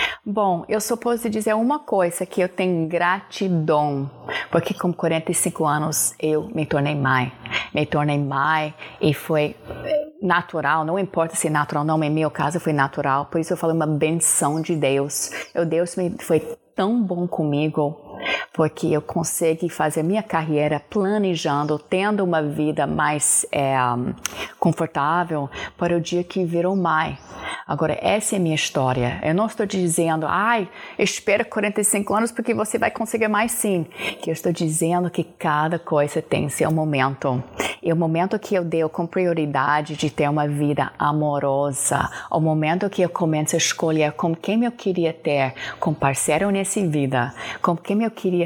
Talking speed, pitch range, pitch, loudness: 165 wpm, 150-185 Hz, 165 Hz, -22 LUFS